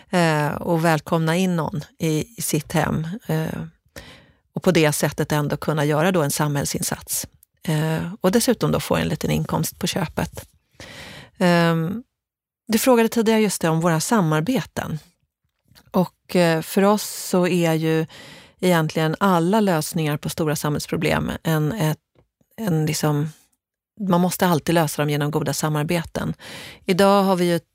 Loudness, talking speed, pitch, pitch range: -21 LUFS, 130 wpm, 165 Hz, 155-185 Hz